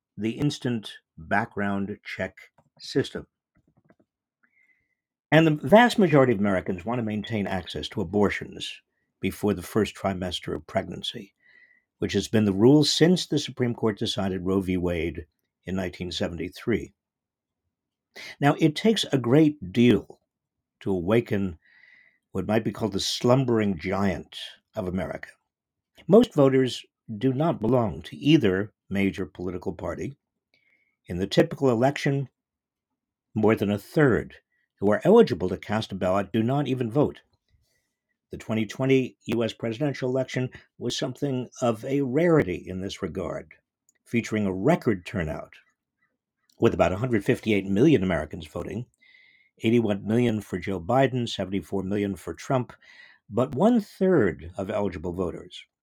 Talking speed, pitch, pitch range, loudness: 130 wpm, 110 Hz, 95-135 Hz, -25 LUFS